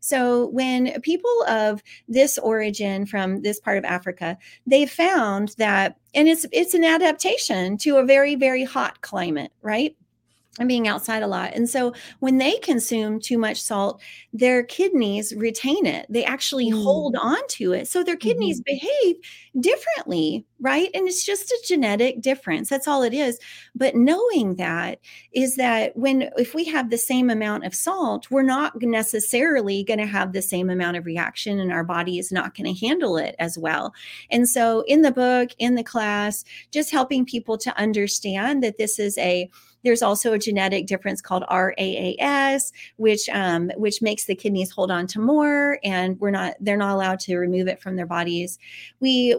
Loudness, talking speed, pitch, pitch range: -22 LUFS, 180 wpm, 235 Hz, 200-275 Hz